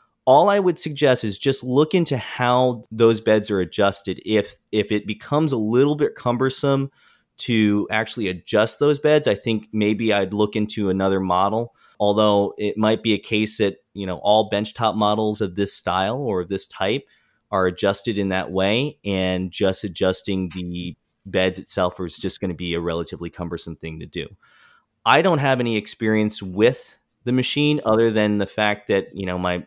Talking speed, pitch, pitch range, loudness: 185 wpm, 105 Hz, 95-115 Hz, -21 LUFS